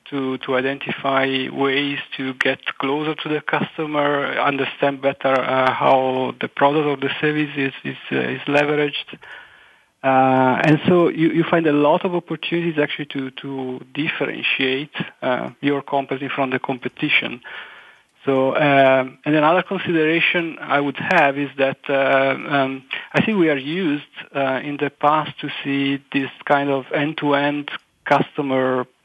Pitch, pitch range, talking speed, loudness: 140 Hz, 135-150 Hz, 155 wpm, -20 LUFS